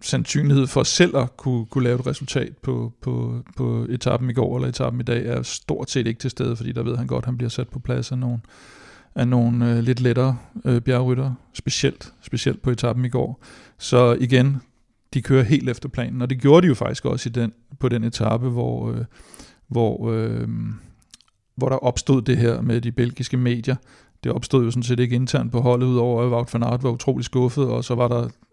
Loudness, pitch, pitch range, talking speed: -22 LUFS, 125 Hz, 120-130 Hz, 215 wpm